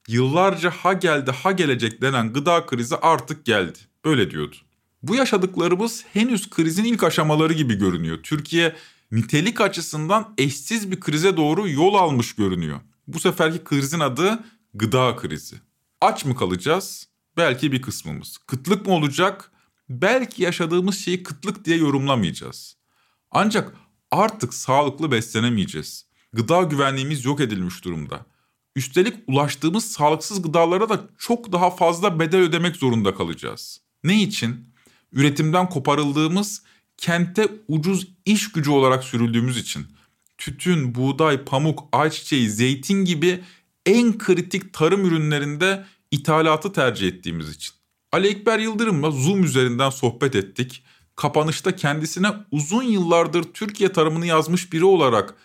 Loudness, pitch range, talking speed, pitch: -21 LUFS, 130-185 Hz, 120 wpm, 160 Hz